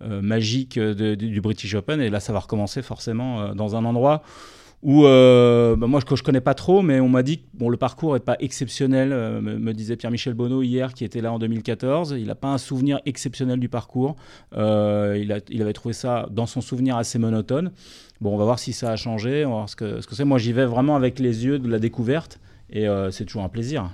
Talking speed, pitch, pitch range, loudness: 255 wpm, 120 Hz, 110-130 Hz, -22 LUFS